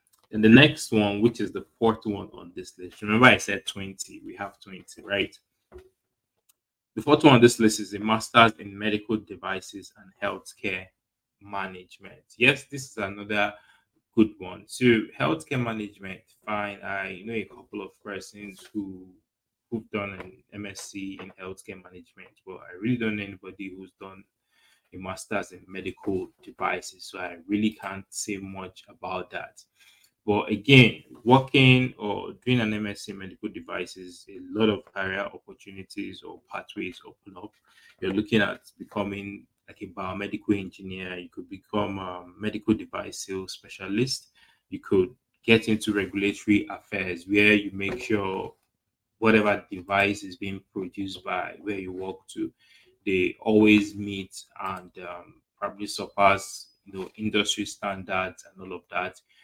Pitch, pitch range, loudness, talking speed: 100 Hz, 95-110 Hz, -25 LUFS, 155 wpm